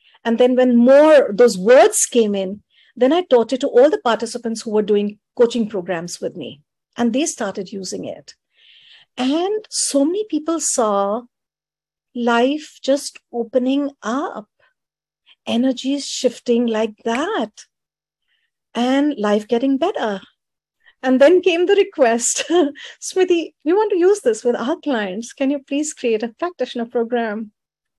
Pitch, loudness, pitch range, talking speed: 250 Hz, -18 LUFS, 230-300 Hz, 140 wpm